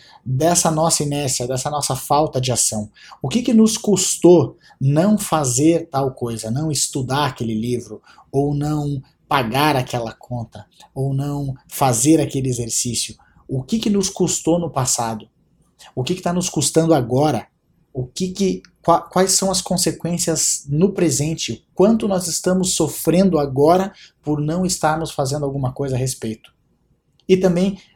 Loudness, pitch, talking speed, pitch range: -19 LUFS, 150 Hz, 145 wpm, 130-175 Hz